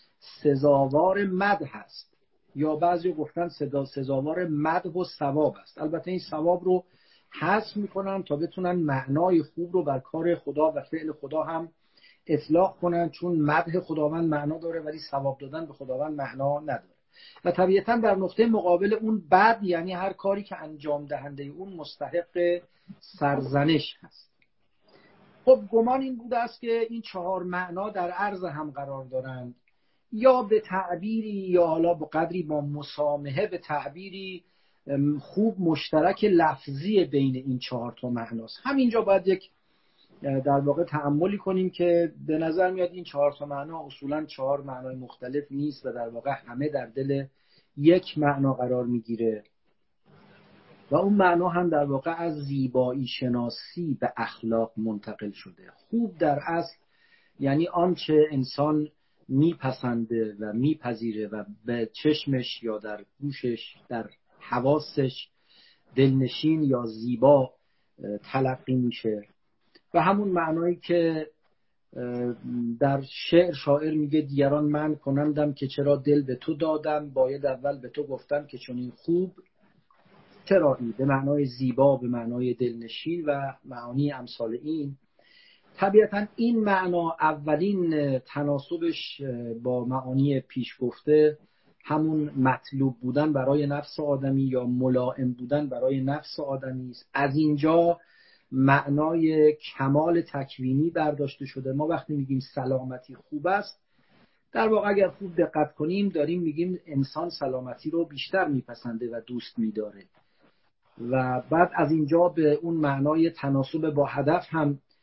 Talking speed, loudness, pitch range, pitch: 135 wpm, -26 LUFS, 135-175 Hz, 150 Hz